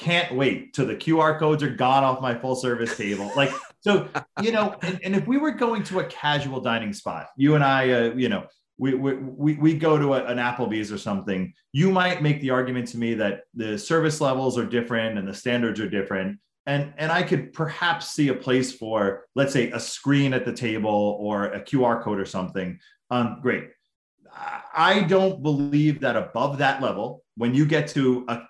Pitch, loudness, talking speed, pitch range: 130 Hz, -24 LUFS, 210 wpm, 115-155 Hz